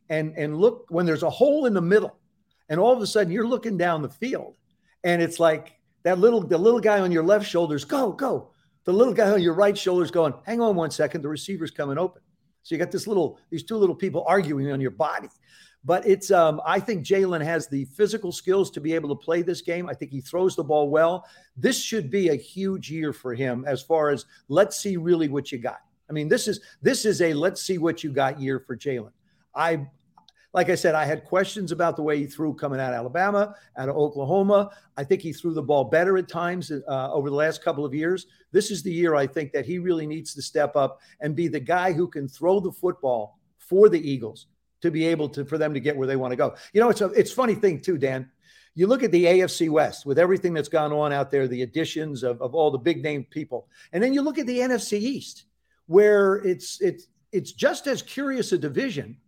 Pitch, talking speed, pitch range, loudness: 170 Hz, 245 wpm, 150-195 Hz, -24 LUFS